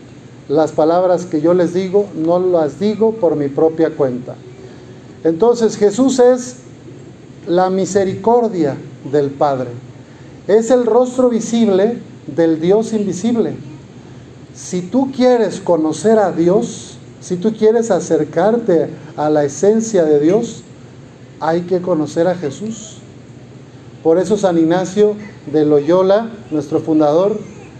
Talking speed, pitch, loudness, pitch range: 120 wpm, 170 Hz, -15 LUFS, 145-210 Hz